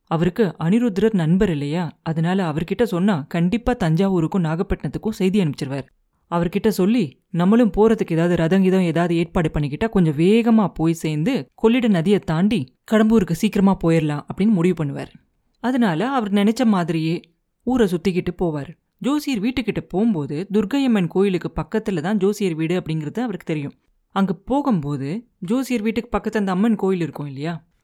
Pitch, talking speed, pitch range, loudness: 185 Hz, 135 wpm, 165-220 Hz, -20 LUFS